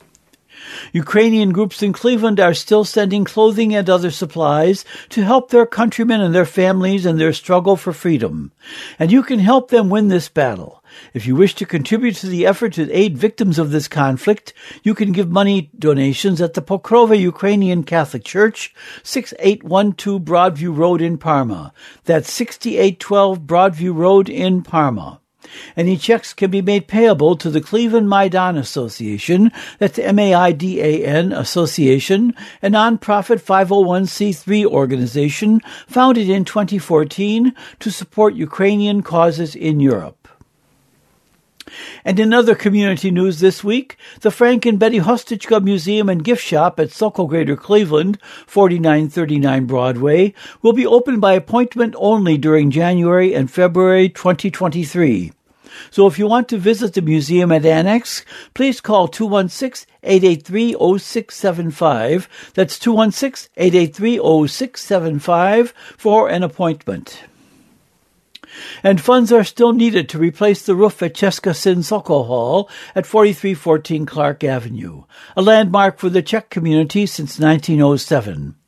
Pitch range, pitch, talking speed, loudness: 165-215 Hz, 190 Hz, 130 wpm, -15 LUFS